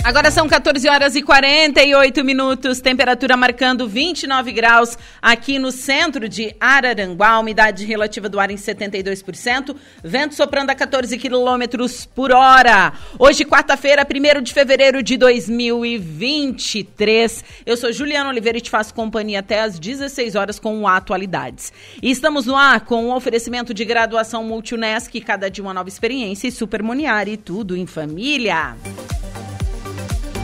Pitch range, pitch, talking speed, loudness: 215-270 Hz, 235 Hz, 140 wpm, -15 LUFS